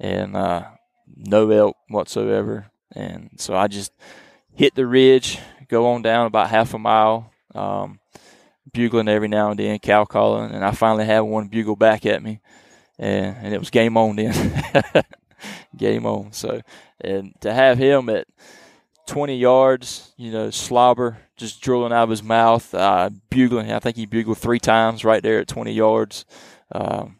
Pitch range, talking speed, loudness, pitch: 105-120 Hz, 170 wpm, -19 LUFS, 110 Hz